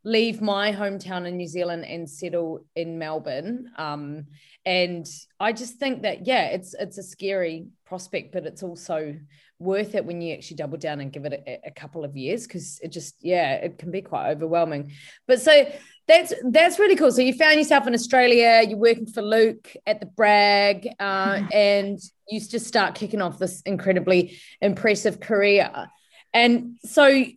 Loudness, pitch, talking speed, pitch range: -21 LUFS, 195 Hz, 180 wpm, 170-230 Hz